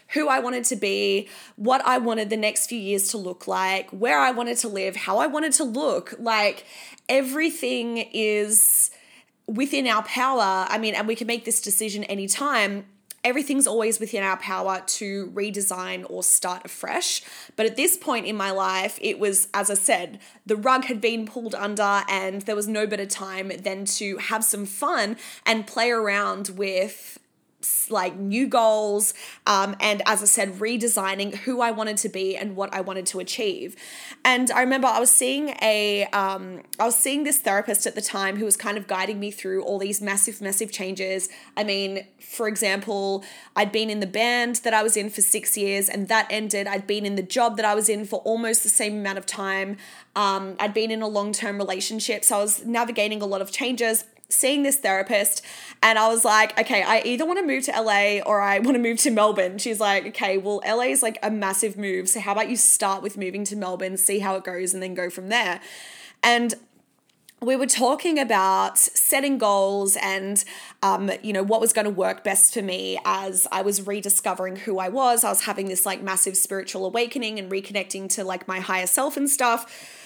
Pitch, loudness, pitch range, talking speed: 210 Hz, -22 LUFS, 195-230 Hz, 205 wpm